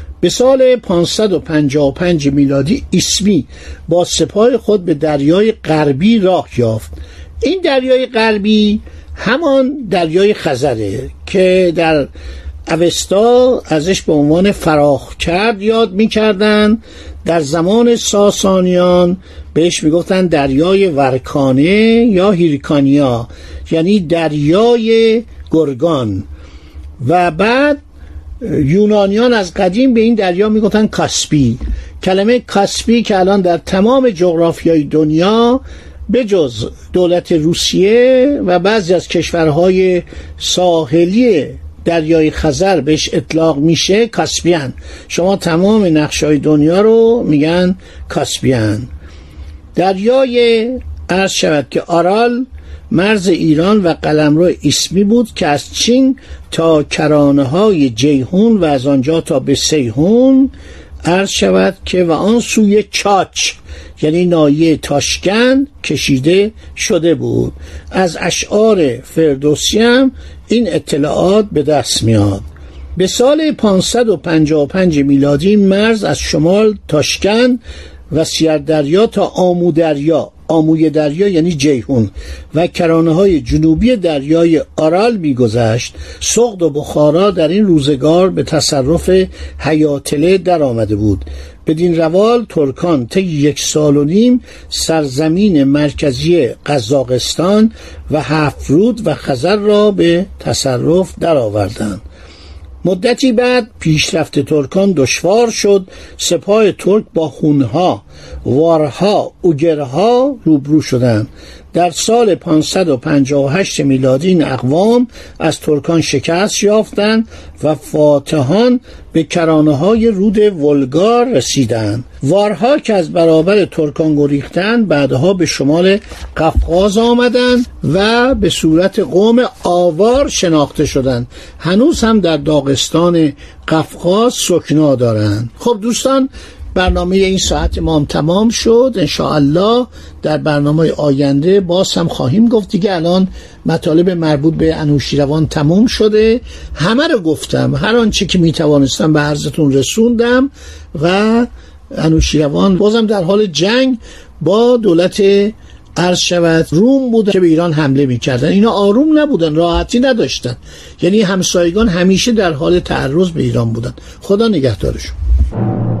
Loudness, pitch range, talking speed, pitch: -12 LUFS, 145-210 Hz, 110 wpm, 170 Hz